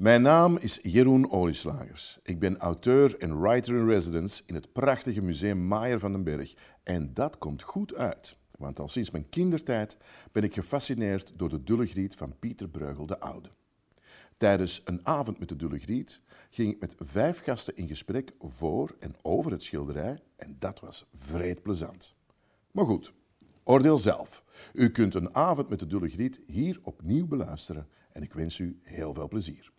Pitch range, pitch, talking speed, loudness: 85-120 Hz, 100 Hz, 175 wpm, -29 LUFS